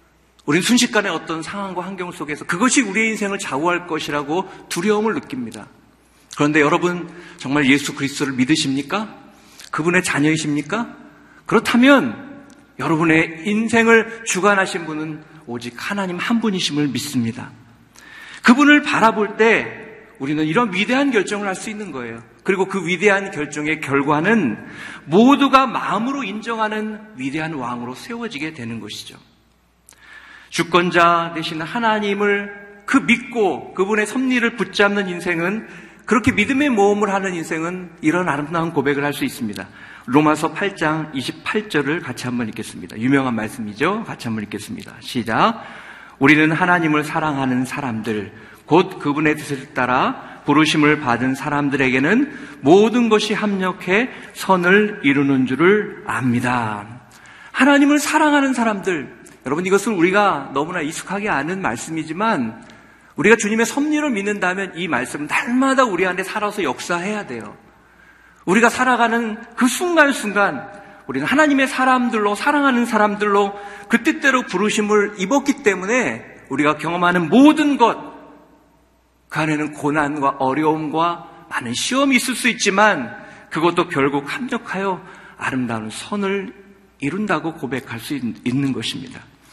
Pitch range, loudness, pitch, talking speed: 150-225 Hz, -18 LUFS, 185 Hz, 320 characters per minute